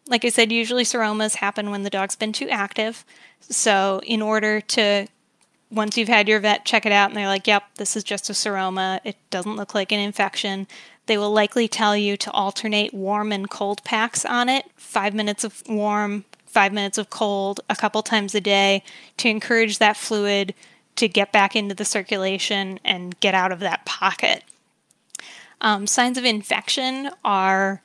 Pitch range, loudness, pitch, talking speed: 200-220 Hz, -21 LUFS, 210 Hz, 185 wpm